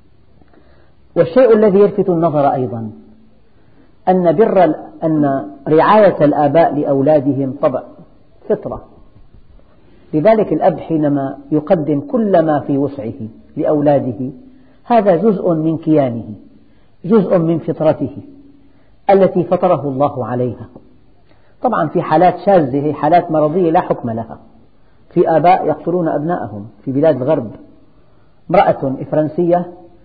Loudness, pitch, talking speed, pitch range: -14 LUFS, 155 Hz, 100 wpm, 140-180 Hz